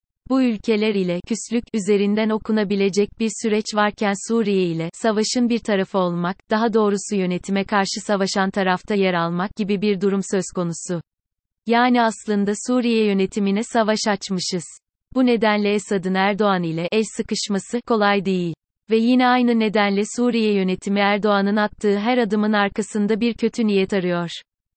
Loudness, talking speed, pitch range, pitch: -20 LUFS, 140 wpm, 195-220 Hz, 205 Hz